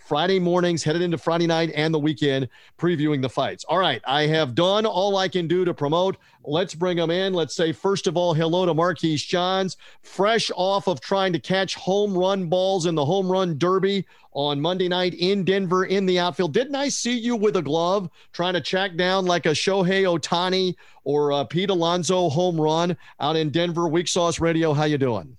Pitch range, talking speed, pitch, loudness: 165-190 Hz, 210 wpm, 175 Hz, -22 LUFS